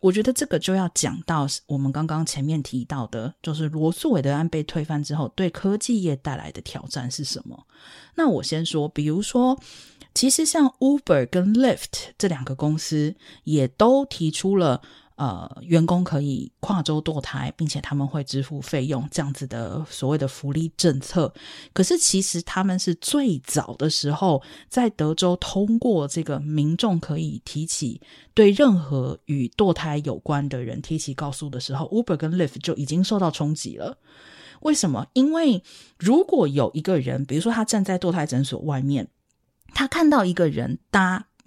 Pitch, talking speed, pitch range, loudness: 160 Hz, 275 characters per minute, 140-190 Hz, -23 LUFS